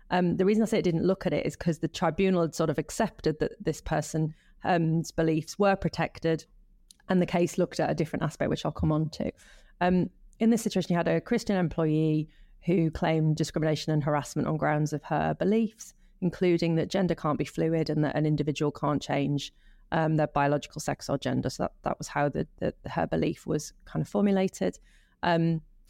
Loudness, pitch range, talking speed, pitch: -28 LUFS, 155-180 Hz, 205 wpm, 165 Hz